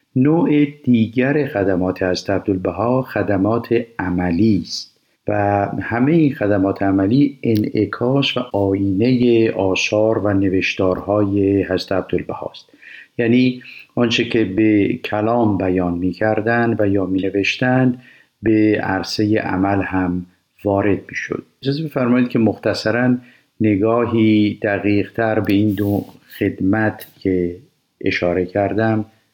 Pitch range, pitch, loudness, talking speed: 95-120 Hz, 105 Hz, -18 LUFS, 110 wpm